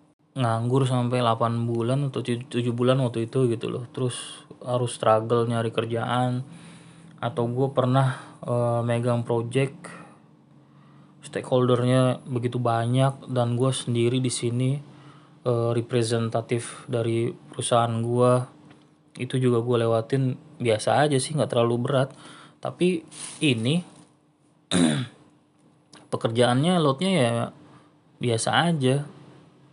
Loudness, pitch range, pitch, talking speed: -24 LUFS, 120-145 Hz, 125 Hz, 105 wpm